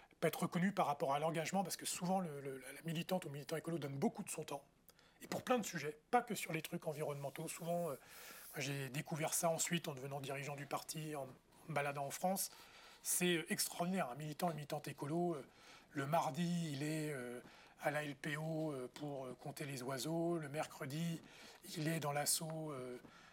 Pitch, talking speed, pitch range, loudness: 155 Hz, 210 wpm, 145-170 Hz, -42 LUFS